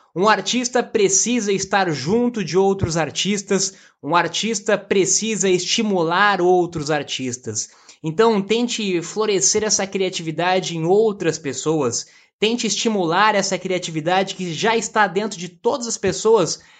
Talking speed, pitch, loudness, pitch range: 120 wpm, 195 Hz, -19 LUFS, 175-215 Hz